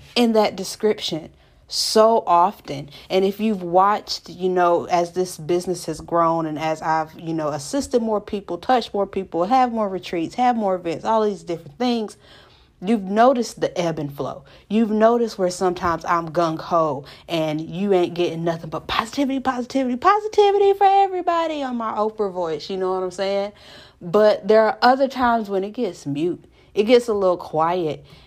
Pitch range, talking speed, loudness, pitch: 170-230 Hz, 180 wpm, -21 LUFS, 195 Hz